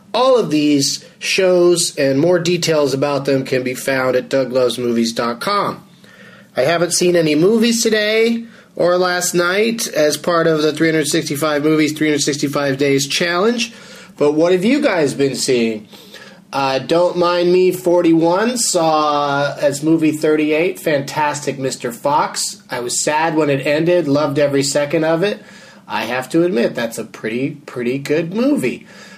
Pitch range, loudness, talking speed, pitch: 140-180 Hz, -16 LUFS, 150 wpm, 155 Hz